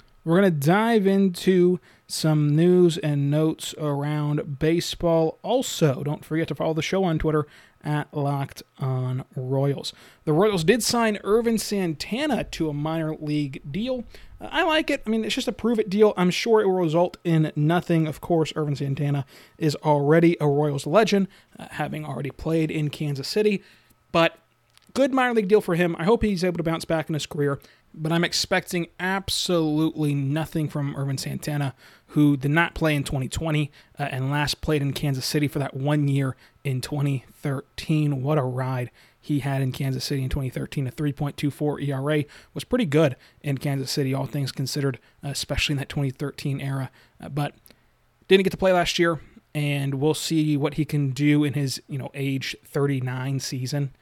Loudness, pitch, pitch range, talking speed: -24 LUFS, 150 Hz, 140-170 Hz, 180 wpm